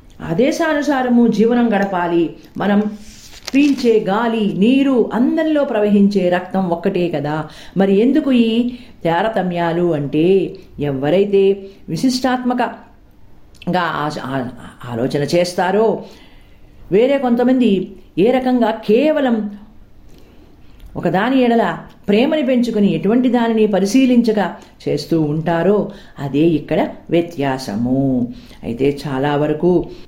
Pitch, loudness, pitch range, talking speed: 200 Hz, -16 LUFS, 170-240 Hz, 80 wpm